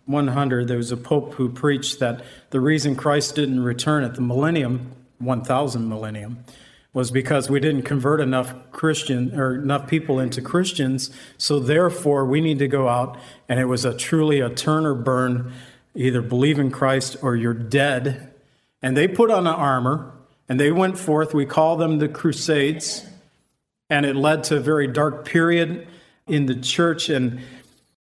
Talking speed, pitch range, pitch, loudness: 170 wpm, 130-150 Hz, 140 Hz, -21 LUFS